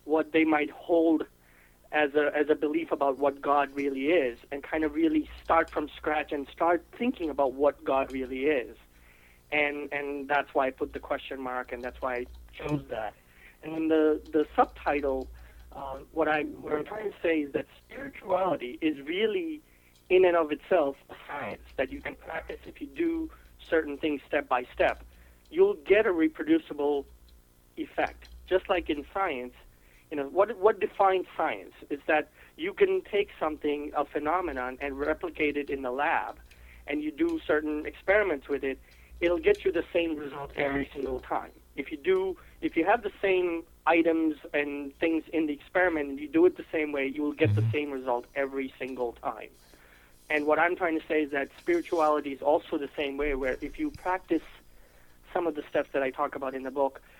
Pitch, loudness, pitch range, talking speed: 150 Hz, -29 LUFS, 135-175 Hz, 195 wpm